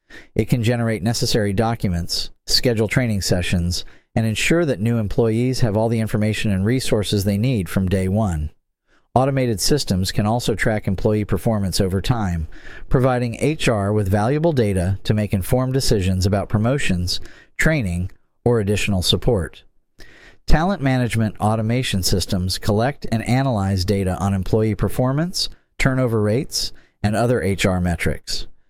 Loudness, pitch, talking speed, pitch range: -20 LUFS, 105 Hz, 135 wpm, 95-120 Hz